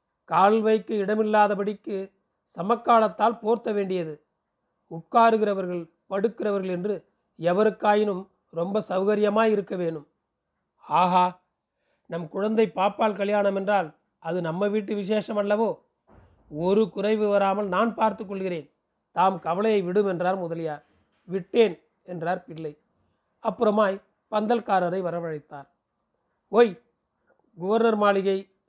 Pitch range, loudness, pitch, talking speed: 180-215 Hz, -24 LUFS, 200 Hz, 90 wpm